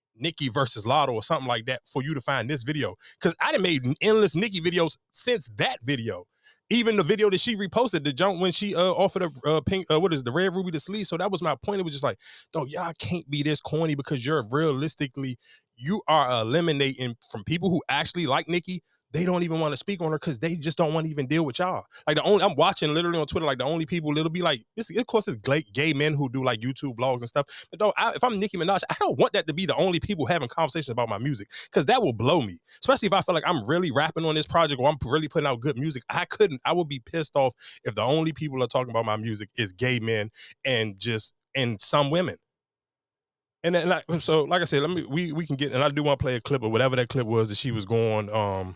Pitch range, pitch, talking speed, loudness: 130-175 Hz, 155 Hz, 265 wpm, -26 LUFS